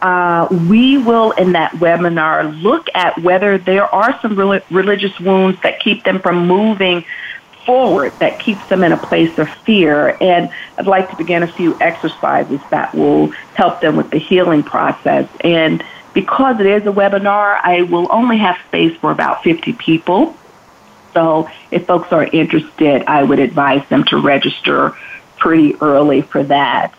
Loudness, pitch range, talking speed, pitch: -13 LUFS, 165-200 Hz, 165 wpm, 185 Hz